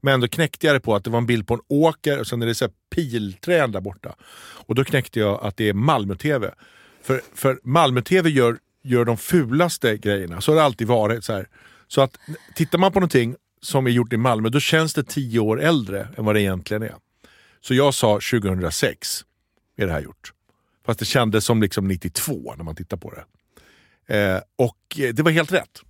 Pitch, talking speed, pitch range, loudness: 120 Hz, 215 wpm, 105-145 Hz, -21 LUFS